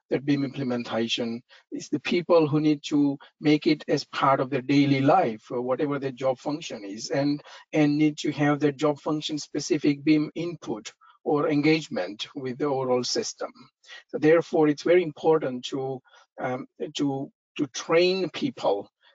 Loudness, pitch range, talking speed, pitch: -25 LUFS, 135-155 Hz, 160 wpm, 145 Hz